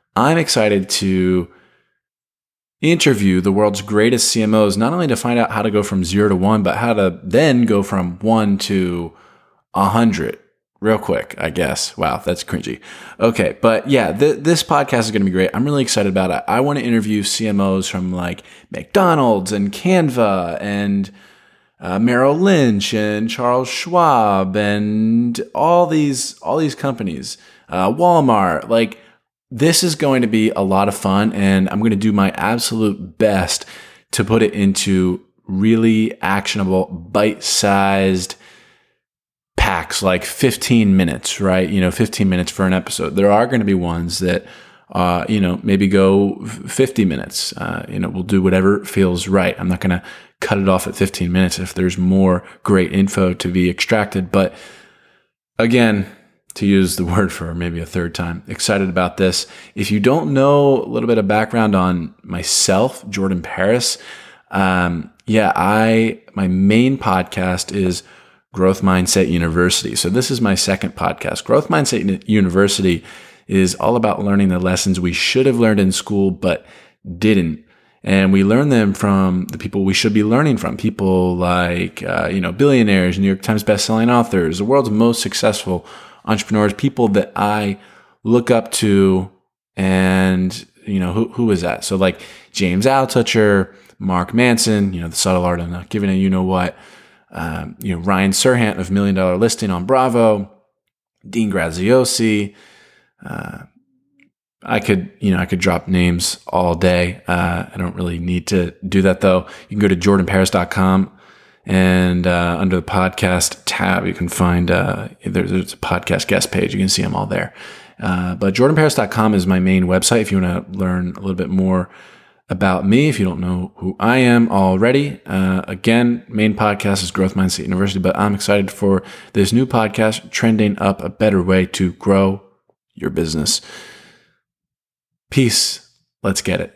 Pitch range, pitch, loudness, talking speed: 95-110 Hz, 100 Hz, -16 LUFS, 170 wpm